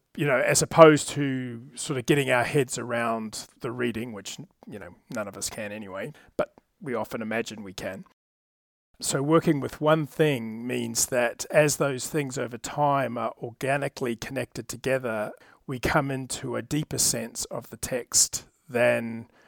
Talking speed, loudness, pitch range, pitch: 165 wpm, -26 LUFS, 120-145 Hz, 130 Hz